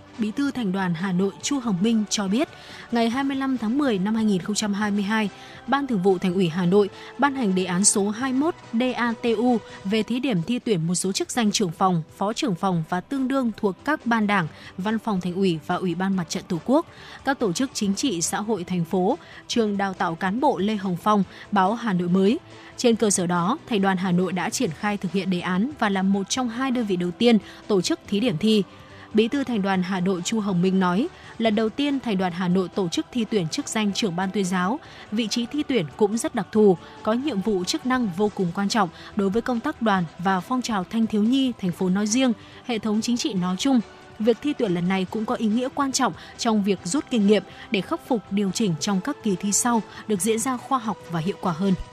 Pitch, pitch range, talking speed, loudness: 210 Hz, 190-240 Hz, 245 wpm, -24 LUFS